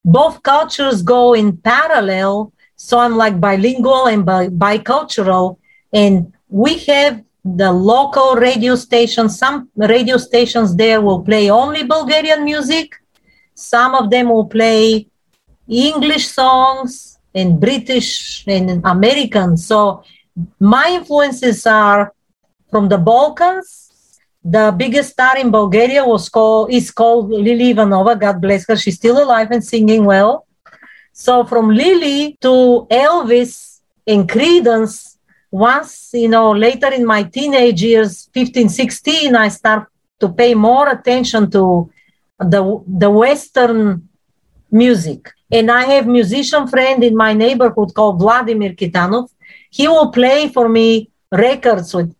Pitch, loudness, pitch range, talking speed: 230 Hz, -12 LUFS, 205-255 Hz, 130 wpm